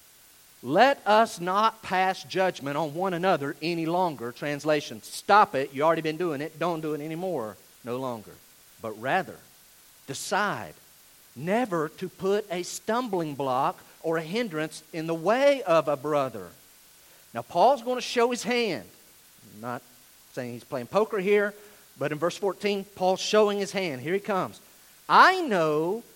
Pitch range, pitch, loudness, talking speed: 155-205 Hz, 180 Hz, -26 LUFS, 160 wpm